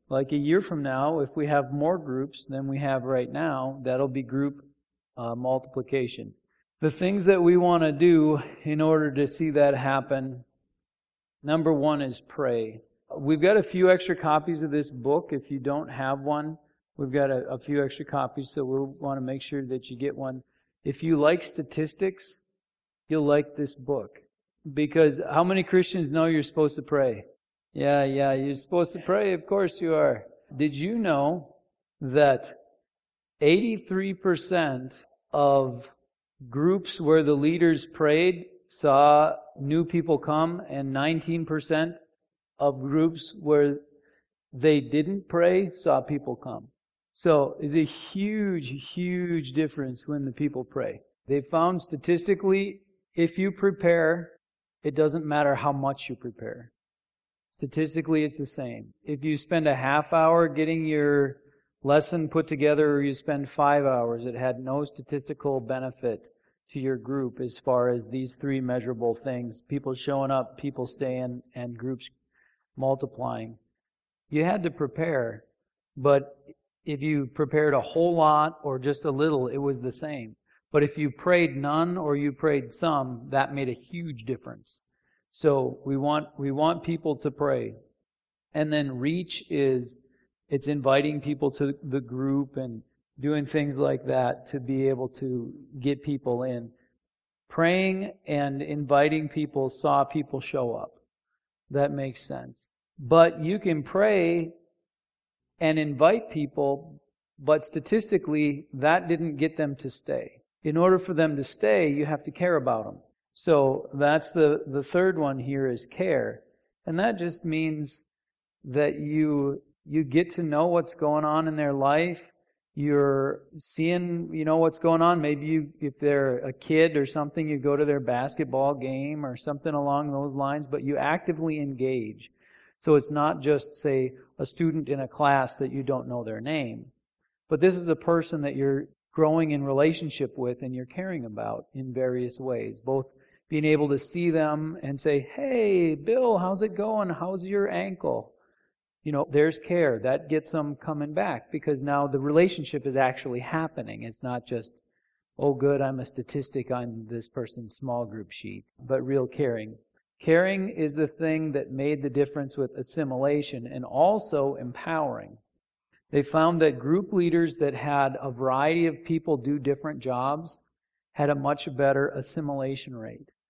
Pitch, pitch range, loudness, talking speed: 145 Hz, 135-160 Hz, -26 LUFS, 160 wpm